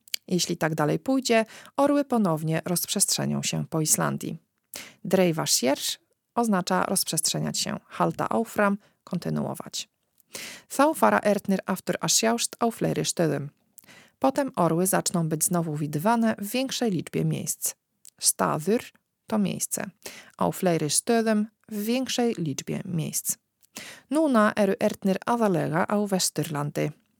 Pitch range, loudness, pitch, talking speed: 165-225 Hz, -25 LUFS, 195 Hz, 100 wpm